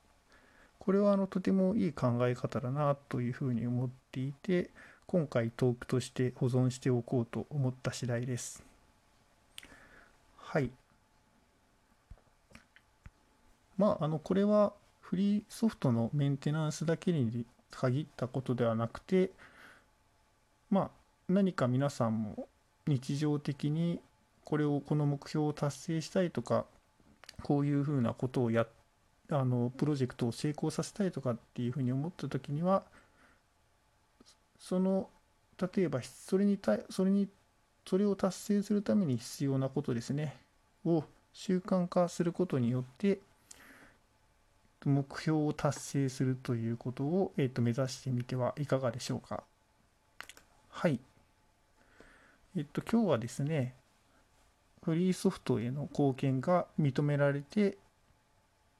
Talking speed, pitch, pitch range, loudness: 260 characters per minute, 140 Hz, 125-175 Hz, -34 LUFS